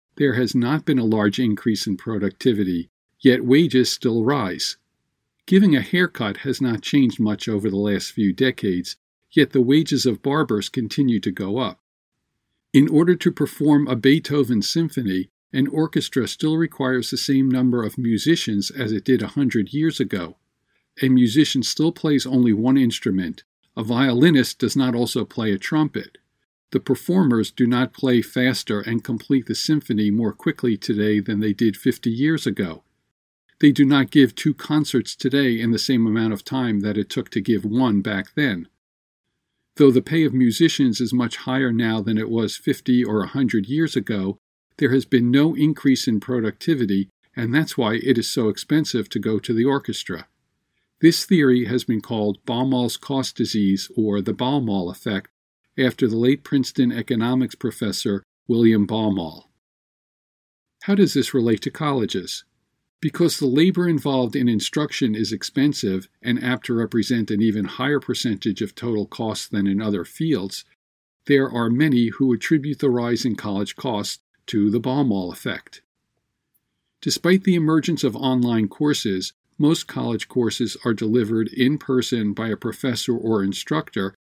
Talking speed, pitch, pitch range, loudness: 165 wpm, 125 Hz, 110-140 Hz, -21 LUFS